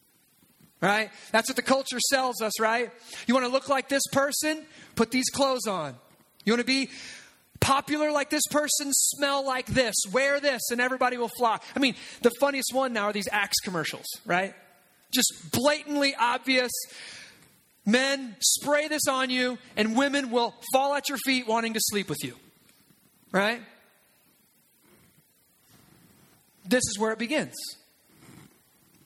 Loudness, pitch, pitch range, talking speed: -26 LUFS, 255 Hz, 225-275 Hz, 150 wpm